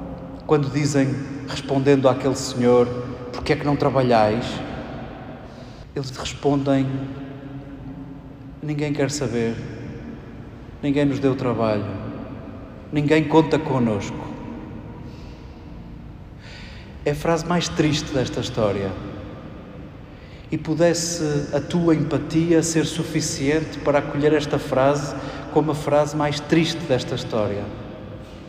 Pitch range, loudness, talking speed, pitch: 120-150 Hz, -22 LUFS, 100 wpm, 135 Hz